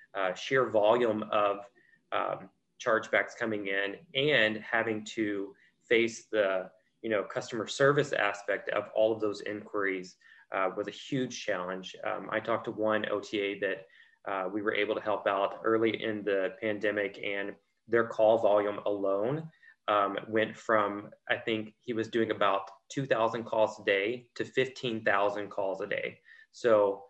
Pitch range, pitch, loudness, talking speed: 100-115 Hz, 110 Hz, -31 LUFS, 160 wpm